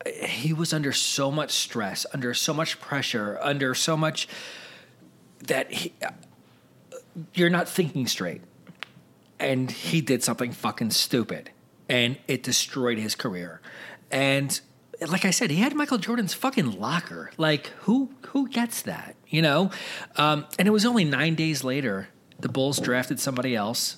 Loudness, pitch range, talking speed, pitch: -25 LUFS, 130-190 Hz, 155 wpm, 150 Hz